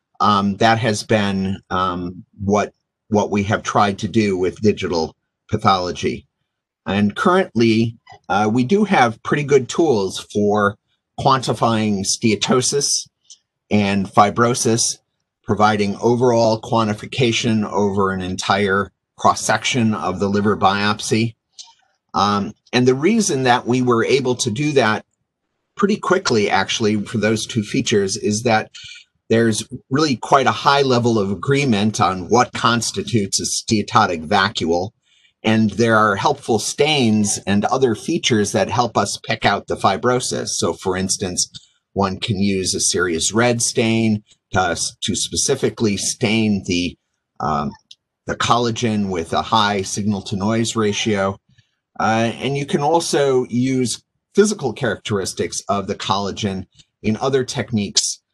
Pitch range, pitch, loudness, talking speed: 100-125 Hz, 110 Hz, -18 LUFS, 135 wpm